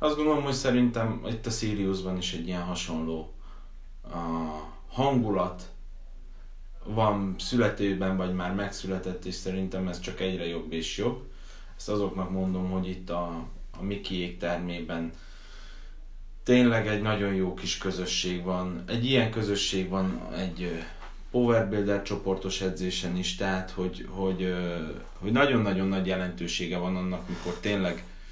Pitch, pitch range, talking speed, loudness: 90 Hz, 85-100 Hz, 135 wpm, -29 LUFS